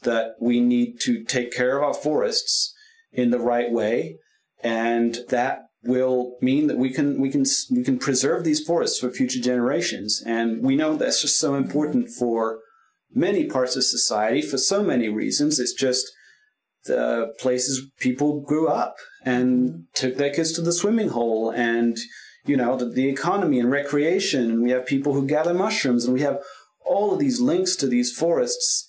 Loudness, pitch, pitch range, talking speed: -22 LUFS, 130 Hz, 120-150 Hz, 180 wpm